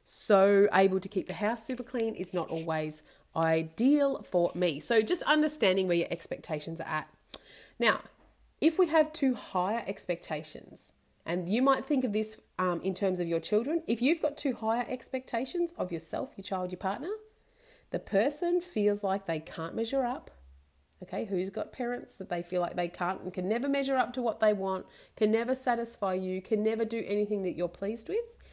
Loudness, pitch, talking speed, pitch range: -30 LUFS, 210 Hz, 195 wpm, 180-255 Hz